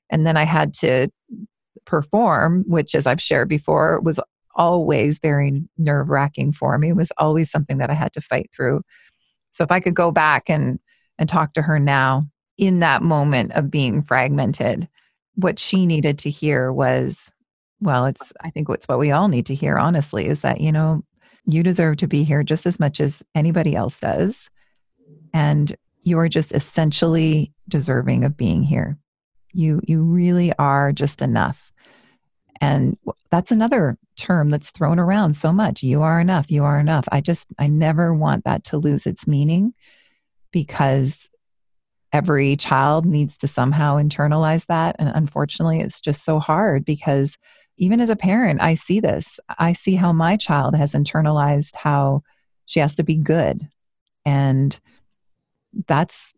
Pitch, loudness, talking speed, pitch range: 155 Hz, -19 LUFS, 165 wpm, 145-170 Hz